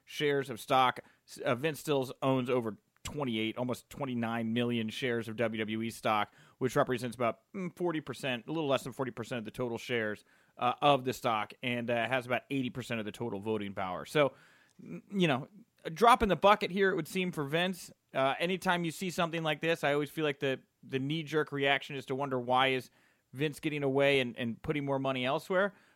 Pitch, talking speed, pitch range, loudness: 135 Hz, 200 wpm, 120-155 Hz, -32 LUFS